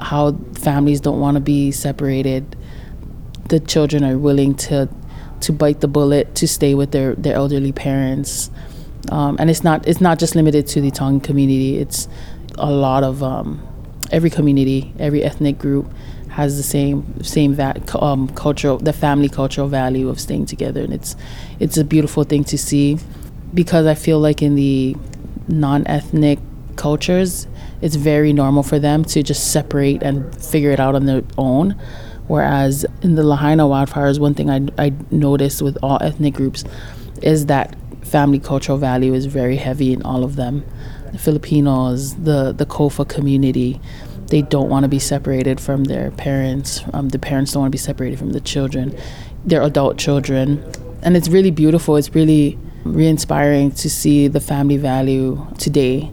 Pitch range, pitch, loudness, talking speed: 135-150 Hz, 140 Hz, -16 LUFS, 170 wpm